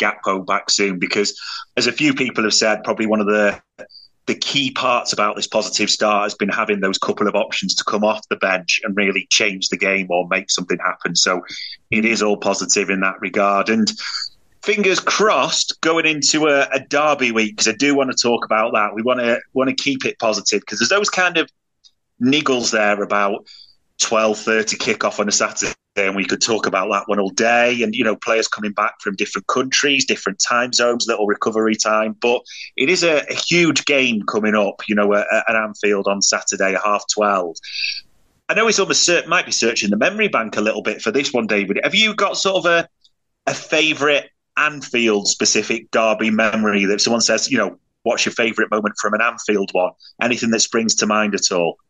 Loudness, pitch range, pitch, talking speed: -17 LUFS, 105-135 Hz, 110 Hz, 210 wpm